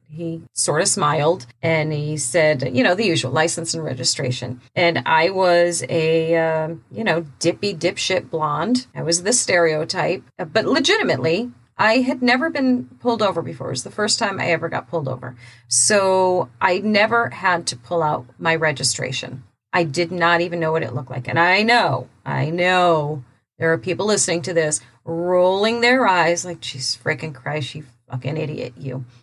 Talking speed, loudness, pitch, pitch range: 180 wpm, -19 LUFS, 165 Hz, 130-180 Hz